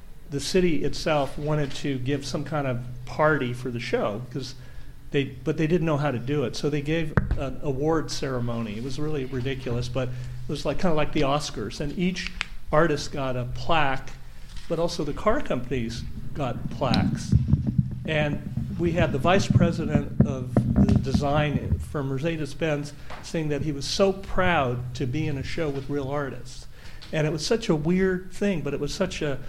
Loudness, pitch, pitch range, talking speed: -26 LUFS, 145 Hz, 130-155 Hz, 190 wpm